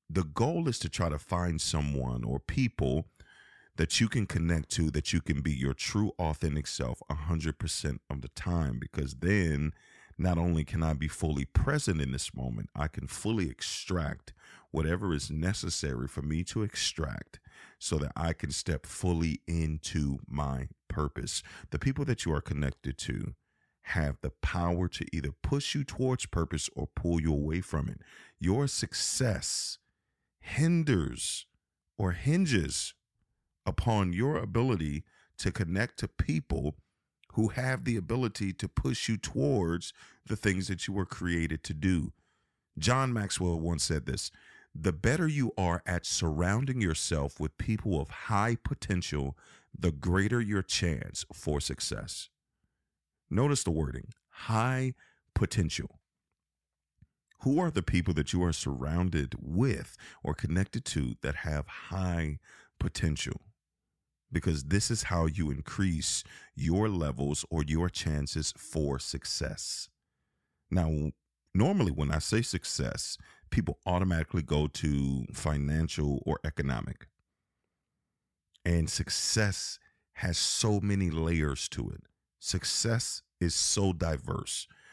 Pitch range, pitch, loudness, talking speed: 75-100 Hz, 85 Hz, -32 LUFS, 135 wpm